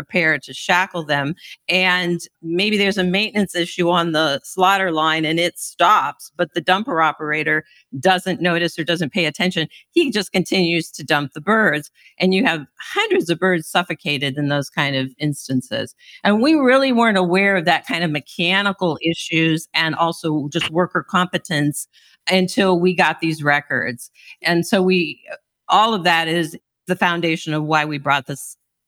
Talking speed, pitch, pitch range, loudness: 170 wpm, 170 Hz, 155-185 Hz, -18 LUFS